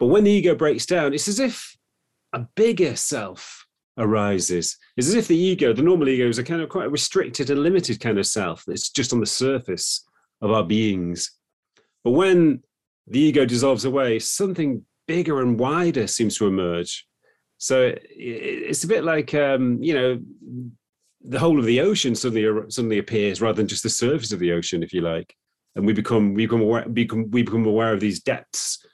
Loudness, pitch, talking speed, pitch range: -21 LUFS, 120 Hz, 195 wpm, 110-150 Hz